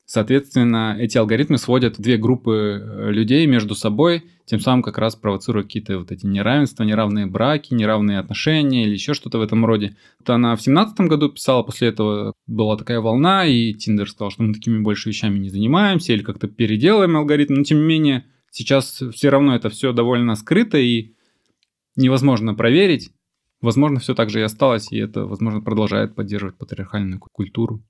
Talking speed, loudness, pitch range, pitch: 175 wpm, -18 LUFS, 105-135 Hz, 115 Hz